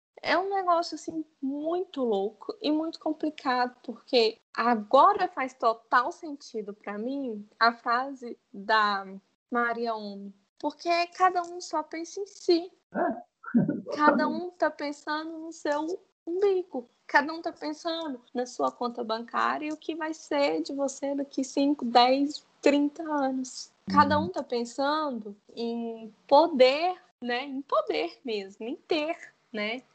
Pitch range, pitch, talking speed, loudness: 240-325 Hz, 280 Hz, 135 wpm, -28 LUFS